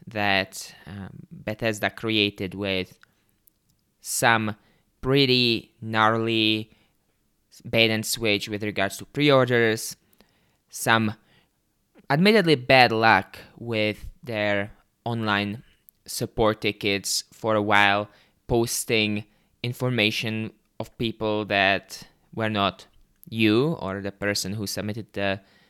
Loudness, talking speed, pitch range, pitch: -23 LUFS, 100 wpm, 100-115 Hz, 110 Hz